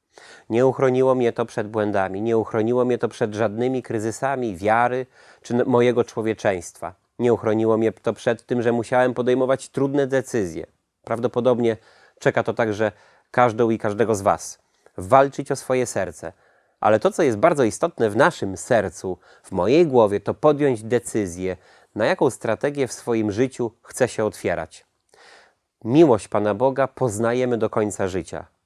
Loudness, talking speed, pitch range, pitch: -21 LUFS, 150 wpm, 110-125 Hz, 120 Hz